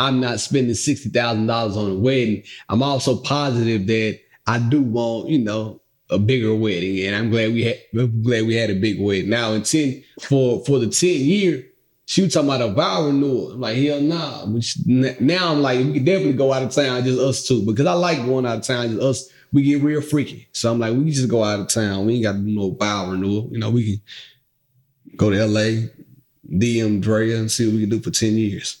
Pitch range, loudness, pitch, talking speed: 110-135 Hz, -20 LUFS, 120 Hz, 240 wpm